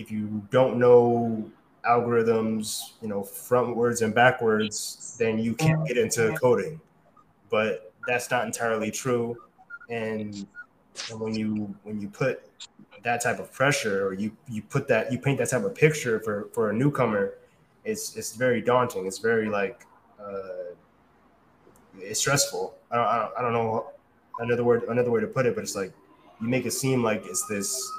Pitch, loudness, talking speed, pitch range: 120 Hz, -26 LUFS, 175 wpm, 110-155 Hz